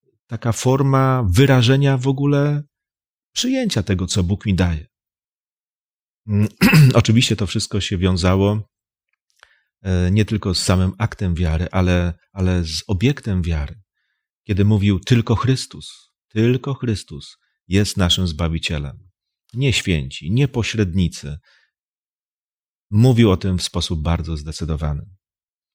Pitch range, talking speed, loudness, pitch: 90-120 Hz, 110 wpm, -18 LUFS, 100 Hz